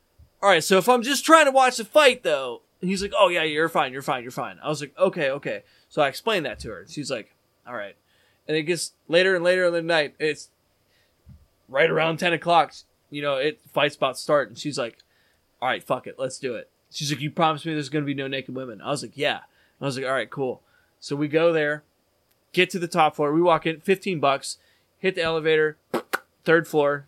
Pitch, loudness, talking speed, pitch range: 155 Hz, -23 LUFS, 235 wpm, 140-180 Hz